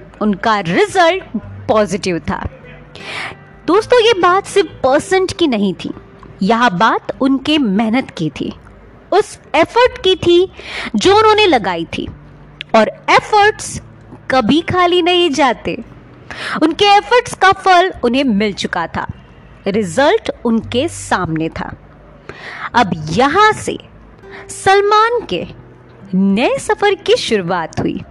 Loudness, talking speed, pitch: -14 LUFS, 115 wpm, 290 Hz